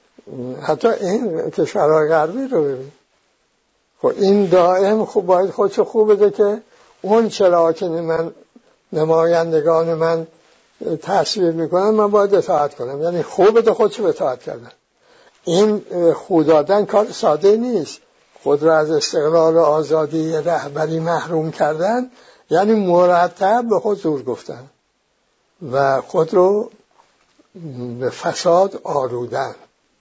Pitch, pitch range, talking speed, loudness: 175 Hz, 160-210 Hz, 125 wpm, -17 LUFS